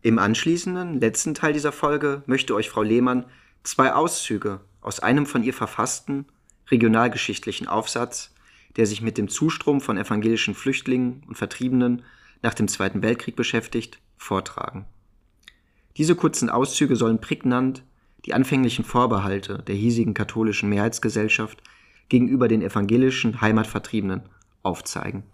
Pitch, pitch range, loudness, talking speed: 115 Hz, 105-130 Hz, -23 LUFS, 125 wpm